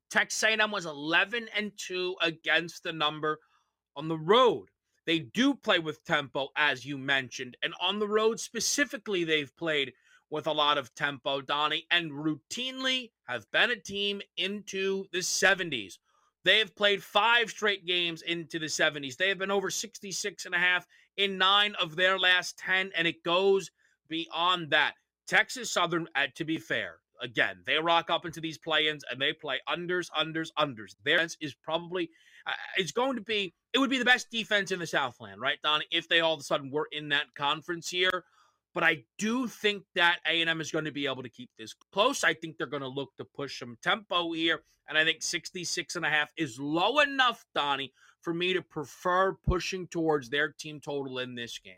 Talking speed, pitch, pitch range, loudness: 195 wpm, 170 Hz, 150-195 Hz, -28 LUFS